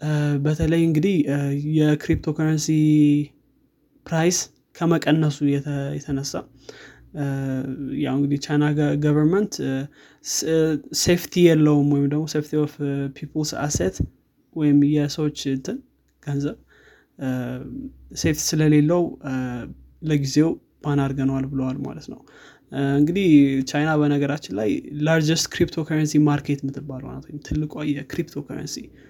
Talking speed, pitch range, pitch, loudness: 80 wpm, 140-155 Hz, 150 Hz, -22 LUFS